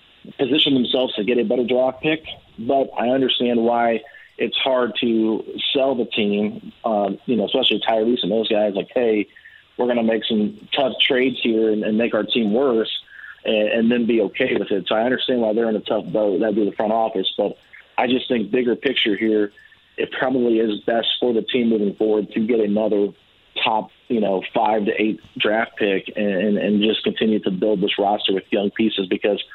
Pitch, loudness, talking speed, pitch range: 115 Hz, -20 LUFS, 210 wpm, 105-125 Hz